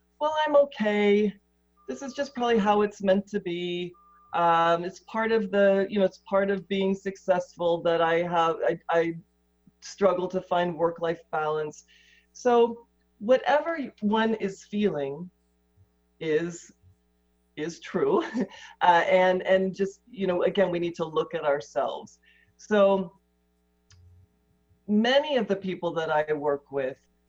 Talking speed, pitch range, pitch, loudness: 145 wpm, 150-205 Hz, 175 Hz, -26 LUFS